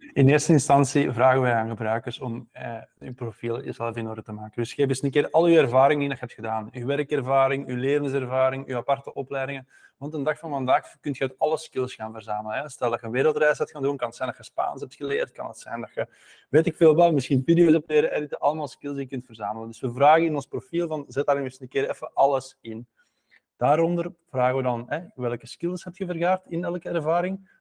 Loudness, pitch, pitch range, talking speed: -24 LUFS, 135 Hz, 125-155 Hz, 245 wpm